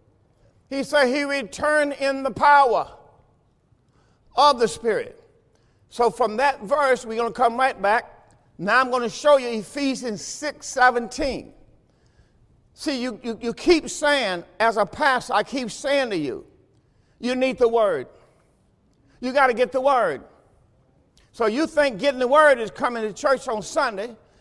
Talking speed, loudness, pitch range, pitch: 160 wpm, -21 LUFS, 230-285 Hz, 260 Hz